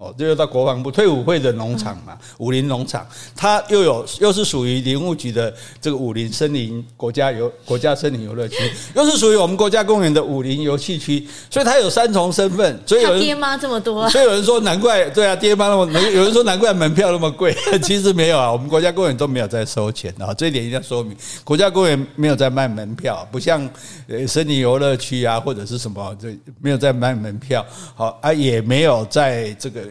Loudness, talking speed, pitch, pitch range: -17 LUFS, 330 characters per minute, 140 Hz, 120-180 Hz